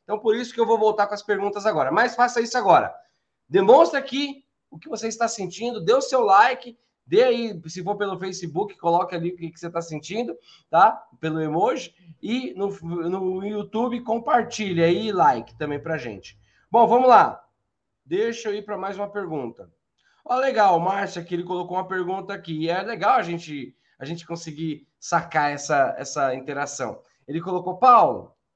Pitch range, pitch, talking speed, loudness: 170-235 Hz, 195 Hz, 185 wpm, -22 LUFS